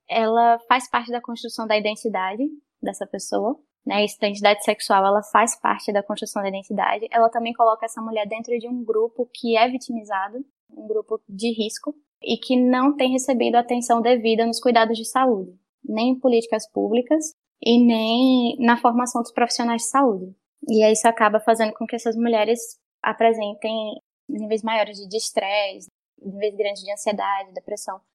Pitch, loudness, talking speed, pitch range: 230 Hz, -21 LUFS, 165 wpm, 215-245 Hz